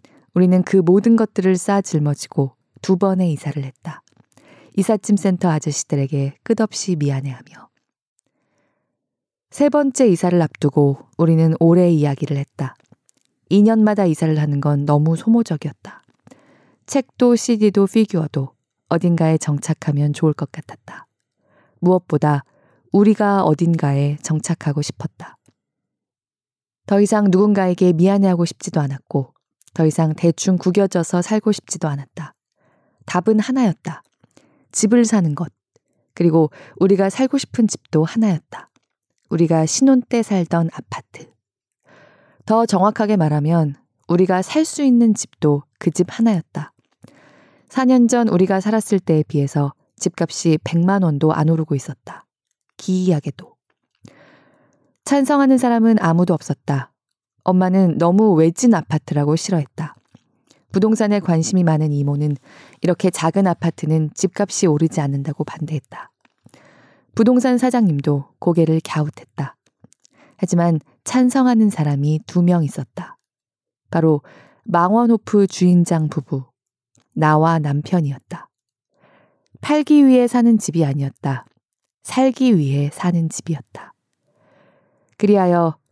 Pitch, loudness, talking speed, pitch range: 170 Hz, -17 LUFS, 270 characters per minute, 150-205 Hz